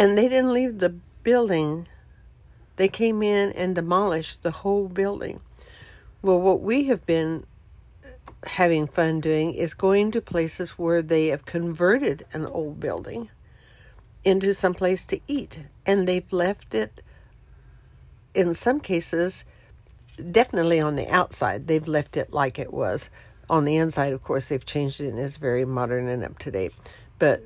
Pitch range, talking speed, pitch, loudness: 150-195 Hz, 155 wpm, 170 Hz, -24 LUFS